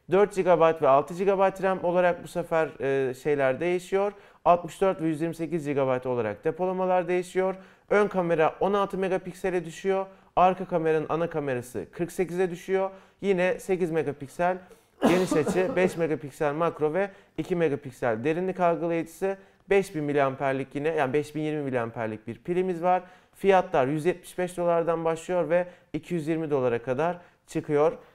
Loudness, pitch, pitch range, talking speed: -26 LUFS, 175 Hz, 155-185 Hz, 130 wpm